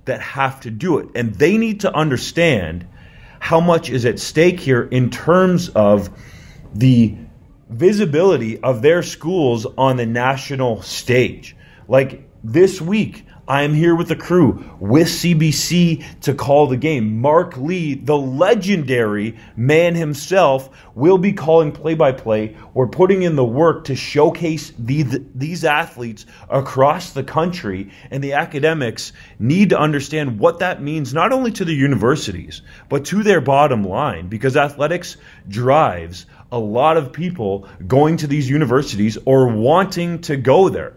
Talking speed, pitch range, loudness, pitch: 150 wpm, 120-165 Hz, -16 LUFS, 140 Hz